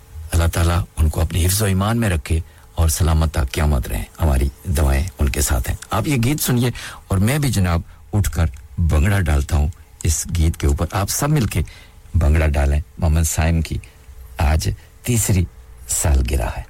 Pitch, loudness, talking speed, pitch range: 85 Hz, -19 LUFS, 190 wpm, 75-95 Hz